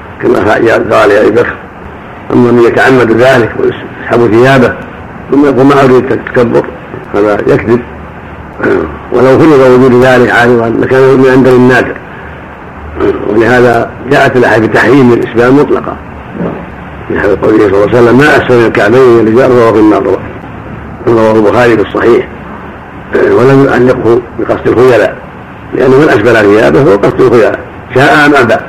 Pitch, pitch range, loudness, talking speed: 125 Hz, 115-130 Hz, -6 LUFS, 135 wpm